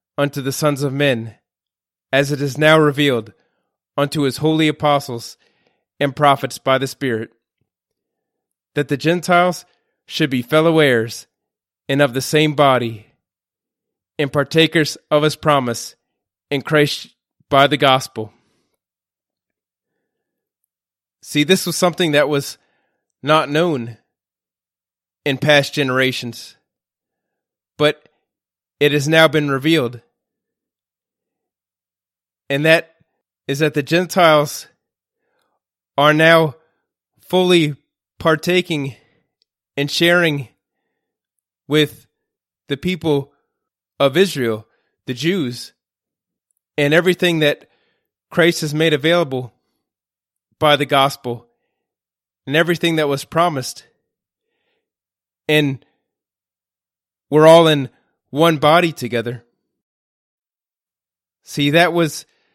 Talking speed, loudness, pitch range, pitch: 100 wpm, -16 LUFS, 120-160 Hz, 145 Hz